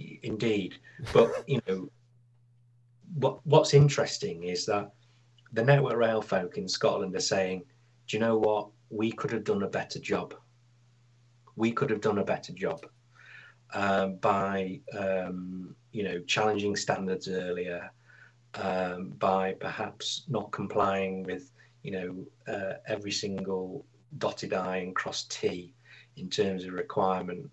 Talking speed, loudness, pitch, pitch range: 135 wpm, -30 LUFS, 105 Hz, 95-120 Hz